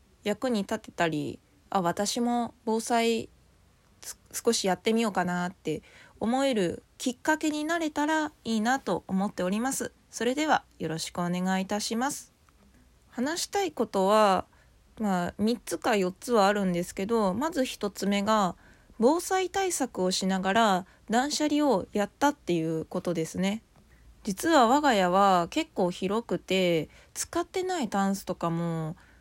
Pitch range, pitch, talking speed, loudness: 185-260 Hz, 215 Hz, 275 characters per minute, -28 LUFS